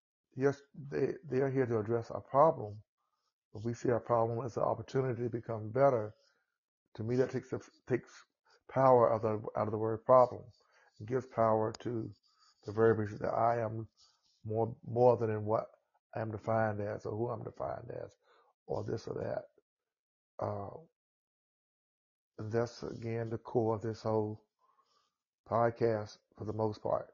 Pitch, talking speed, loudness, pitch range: 115 Hz, 165 wpm, -34 LUFS, 110-120 Hz